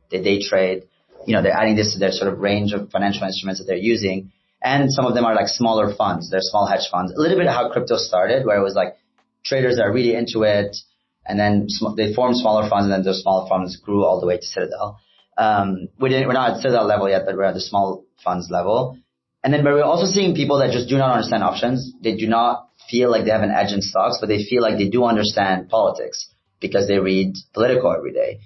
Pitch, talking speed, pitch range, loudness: 105 Hz, 250 wpm, 95-125 Hz, -19 LUFS